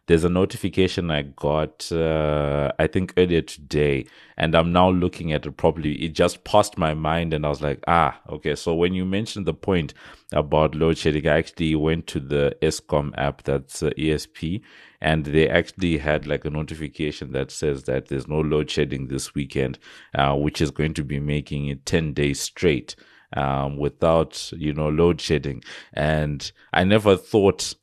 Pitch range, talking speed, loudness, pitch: 75-85 Hz, 180 wpm, -23 LUFS, 75 Hz